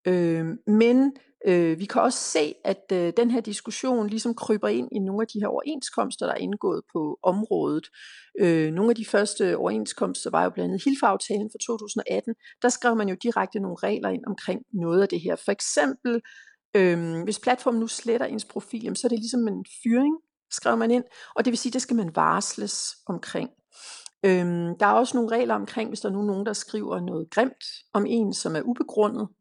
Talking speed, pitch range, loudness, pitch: 205 wpm, 195-240 Hz, -25 LUFS, 220 Hz